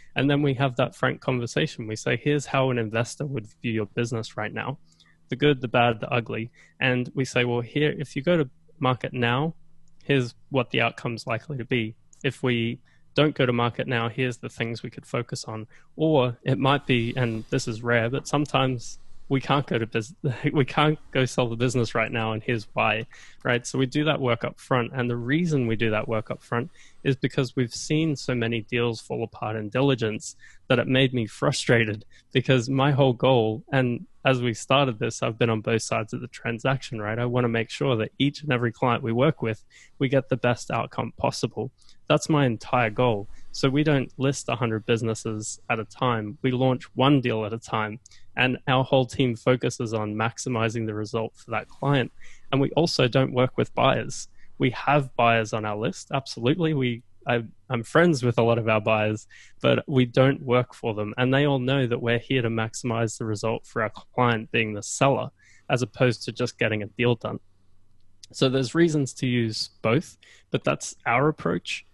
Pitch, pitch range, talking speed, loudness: 125 Hz, 115-135 Hz, 210 wpm, -25 LUFS